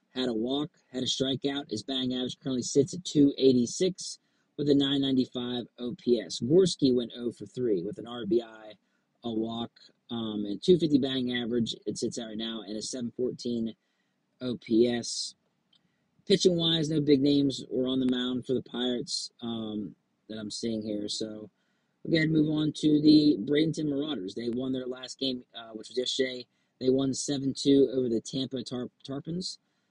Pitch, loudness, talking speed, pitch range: 130 Hz, -29 LUFS, 175 wpm, 120-145 Hz